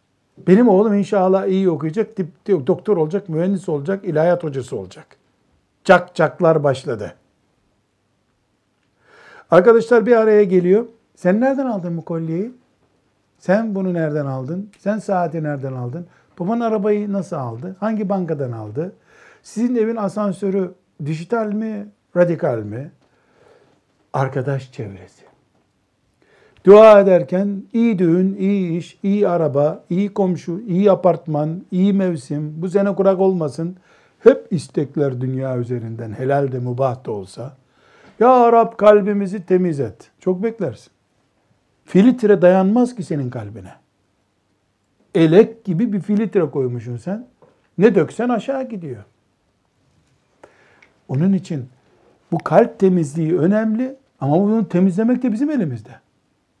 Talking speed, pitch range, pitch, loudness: 120 wpm, 140-205 Hz, 180 Hz, -17 LUFS